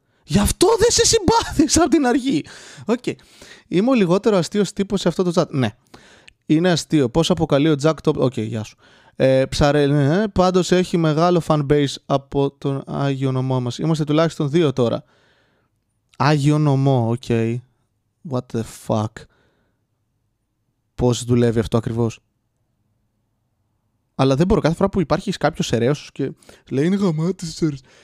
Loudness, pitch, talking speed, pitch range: -19 LUFS, 140 Hz, 150 wpm, 120-175 Hz